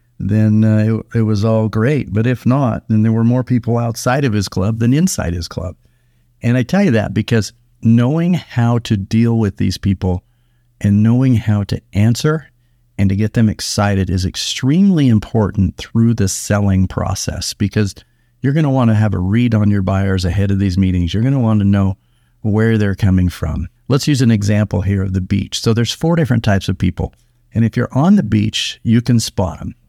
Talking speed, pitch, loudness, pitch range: 210 wpm, 110 Hz, -15 LUFS, 100-120 Hz